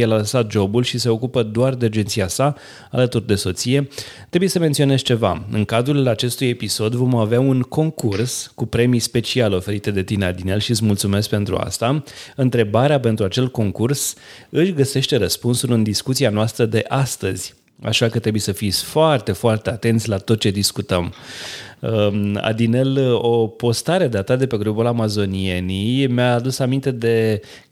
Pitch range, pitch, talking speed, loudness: 105-130 Hz, 115 Hz, 160 wpm, -19 LUFS